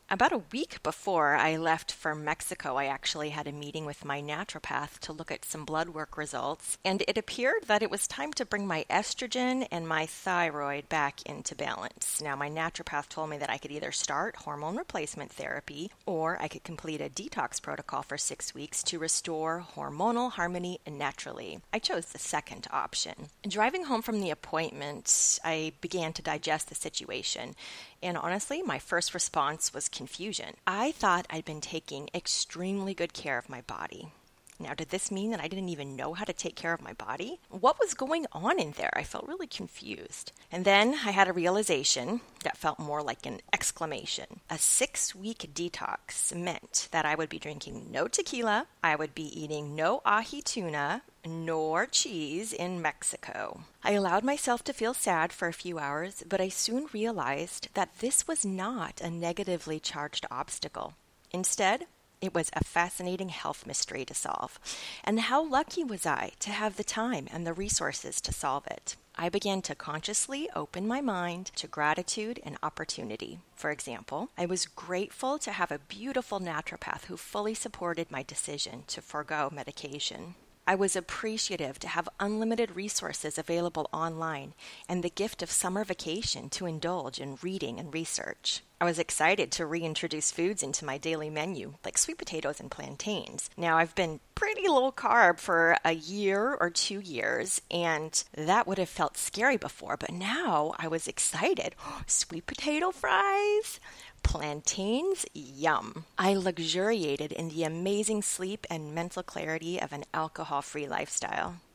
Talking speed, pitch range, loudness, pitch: 170 wpm, 155-205 Hz, -31 LUFS, 175 Hz